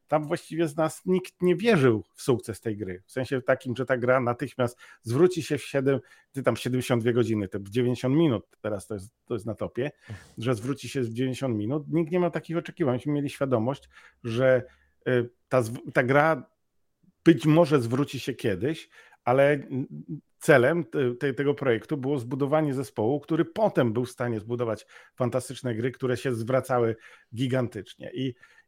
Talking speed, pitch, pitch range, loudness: 165 wpm, 130 Hz, 120-150 Hz, -27 LUFS